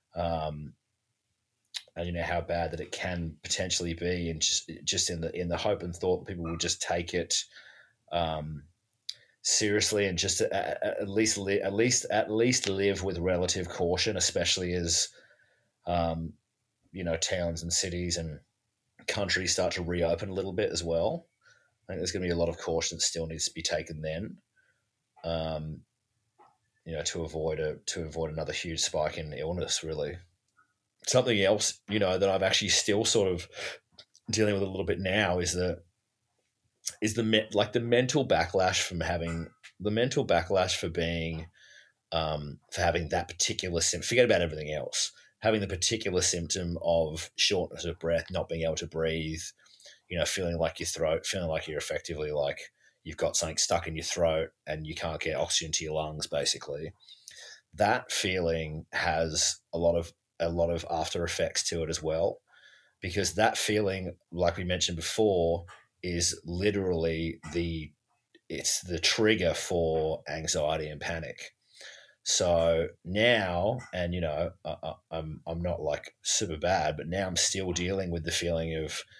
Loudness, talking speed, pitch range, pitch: -29 LUFS, 170 wpm, 80-95 Hz, 85 Hz